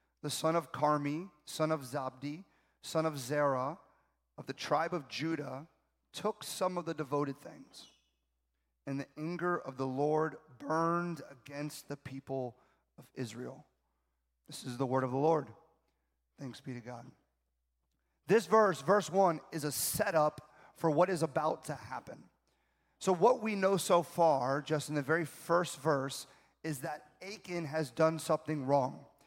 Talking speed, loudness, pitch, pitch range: 155 wpm, -34 LUFS, 150 Hz, 135-165 Hz